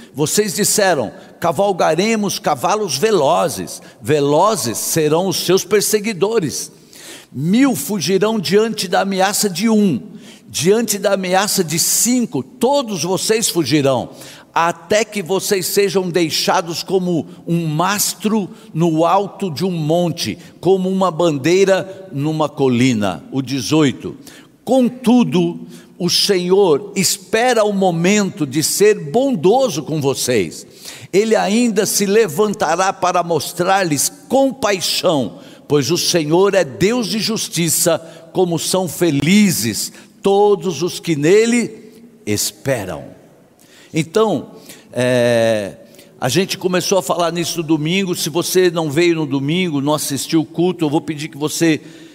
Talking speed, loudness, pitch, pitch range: 120 wpm, -16 LUFS, 185 Hz, 160-205 Hz